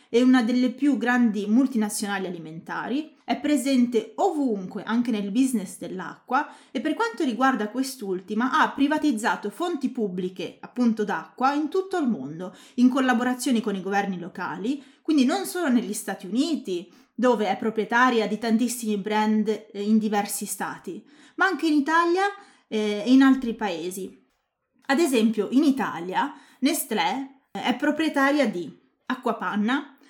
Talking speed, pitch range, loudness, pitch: 135 wpm, 210-280 Hz, -24 LUFS, 245 Hz